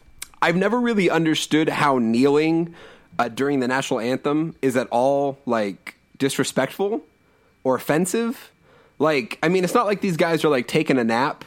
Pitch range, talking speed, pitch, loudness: 130-170 Hz, 160 wpm, 150 Hz, -21 LUFS